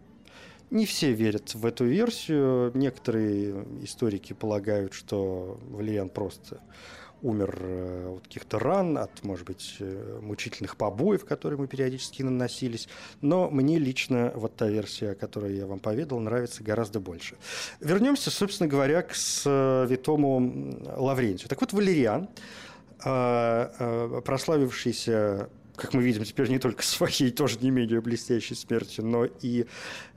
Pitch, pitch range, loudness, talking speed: 120 Hz, 105-135 Hz, -28 LUFS, 125 wpm